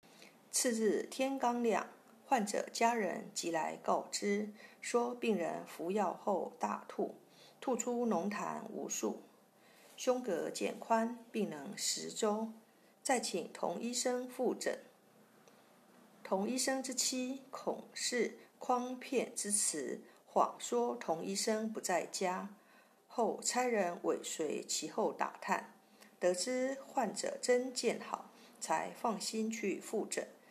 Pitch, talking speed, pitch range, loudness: 235 Hz, 165 characters per minute, 215-255 Hz, -37 LUFS